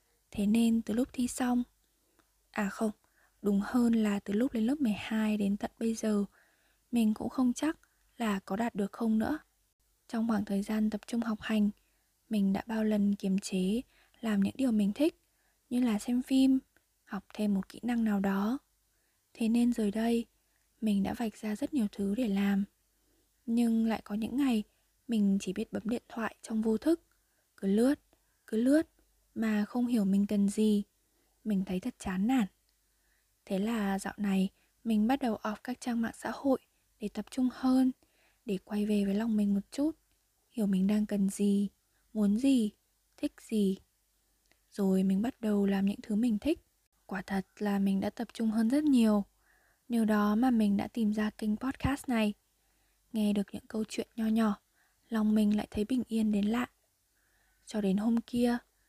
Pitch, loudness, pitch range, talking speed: 220 Hz, -31 LUFS, 205-245 Hz, 185 wpm